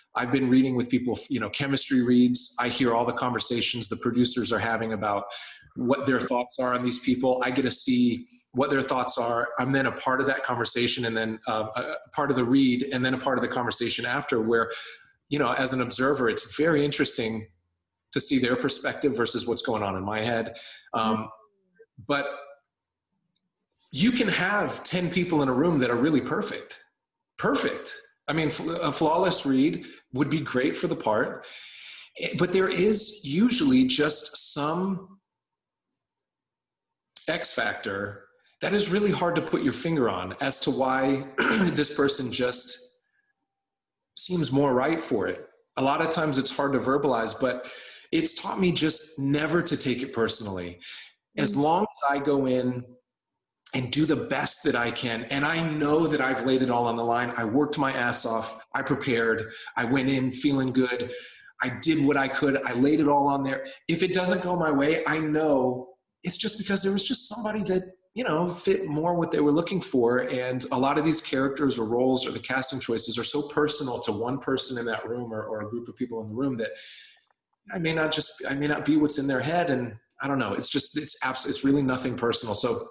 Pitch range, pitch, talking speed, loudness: 125-160 Hz, 135 Hz, 200 wpm, -25 LUFS